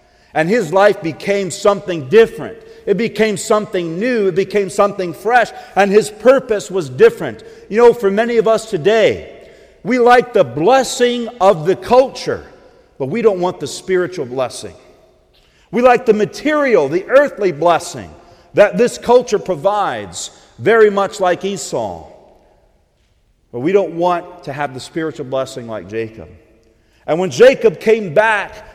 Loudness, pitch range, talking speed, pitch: -15 LUFS, 170-230 Hz, 150 wpm, 200 Hz